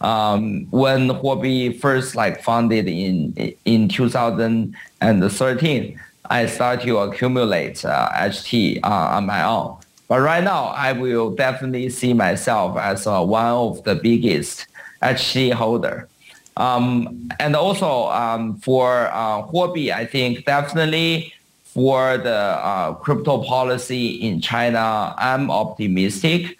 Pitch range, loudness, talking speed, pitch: 115-130 Hz, -19 LUFS, 120 wpm, 125 Hz